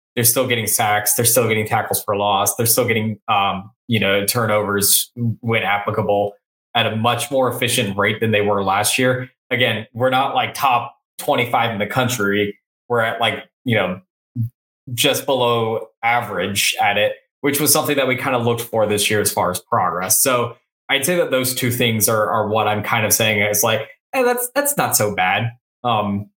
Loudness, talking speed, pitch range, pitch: -18 LUFS, 200 wpm, 105-125 Hz, 115 Hz